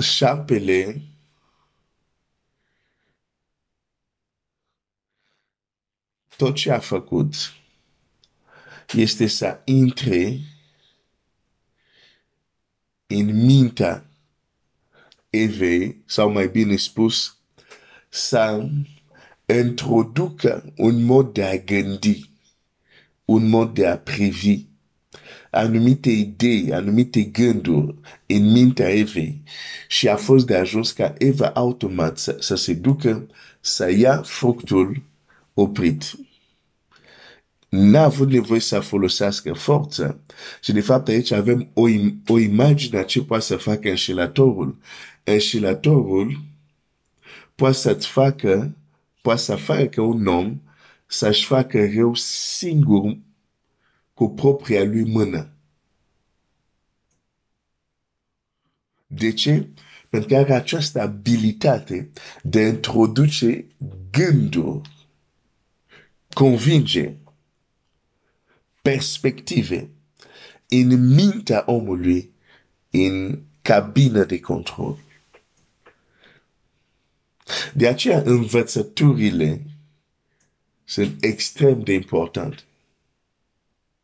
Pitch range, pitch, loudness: 95-130 Hz, 110 Hz, -19 LUFS